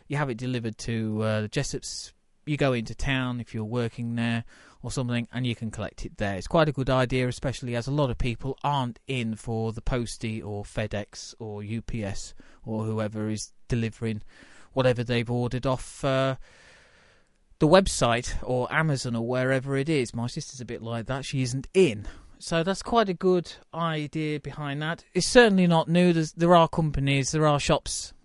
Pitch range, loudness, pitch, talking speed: 115-150 Hz, -26 LUFS, 125 Hz, 190 wpm